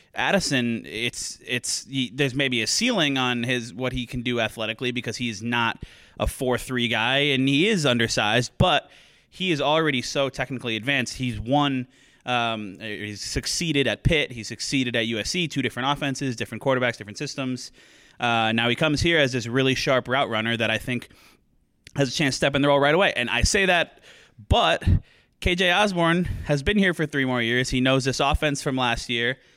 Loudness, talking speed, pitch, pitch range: -23 LUFS, 195 wpm, 130 Hz, 120-140 Hz